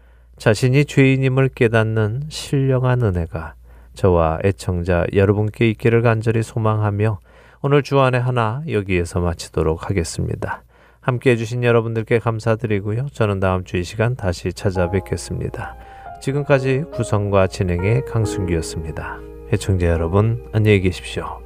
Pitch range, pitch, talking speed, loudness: 90-120 Hz, 105 Hz, 330 characters per minute, -19 LUFS